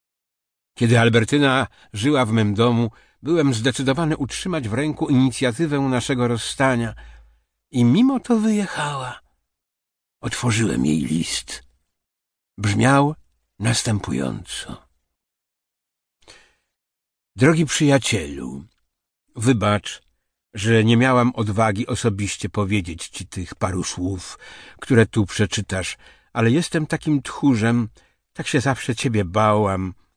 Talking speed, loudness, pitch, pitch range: 95 wpm, -20 LUFS, 120 Hz, 105-135 Hz